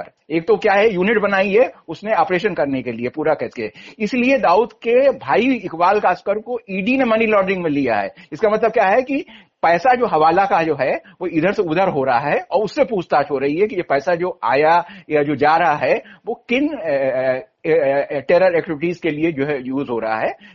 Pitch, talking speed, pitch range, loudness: 180 Hz, 215 wpm, 150-220 Hz, -18 LUFS